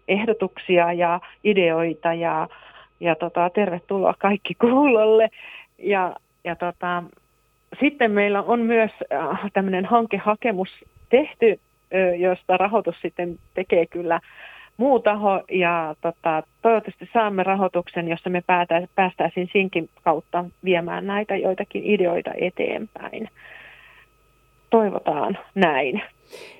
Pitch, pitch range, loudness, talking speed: 185 Hz, 175-210 Hz, -22 LUFS, 100 wpm